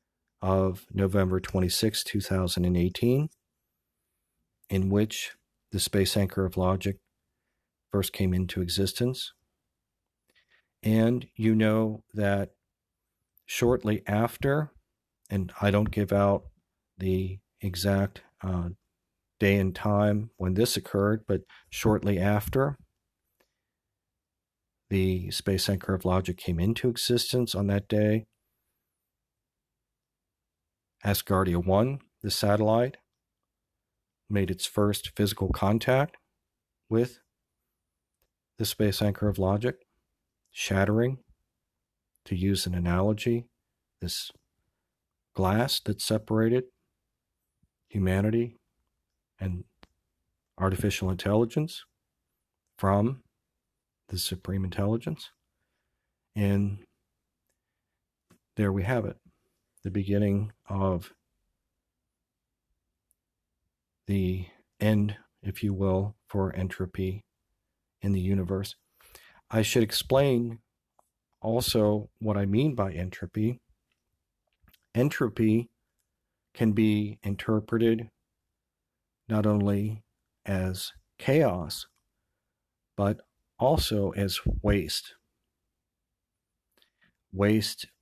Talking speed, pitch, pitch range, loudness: 80 wpm, 100 Hz, 95-110 Hz, -28 LUFS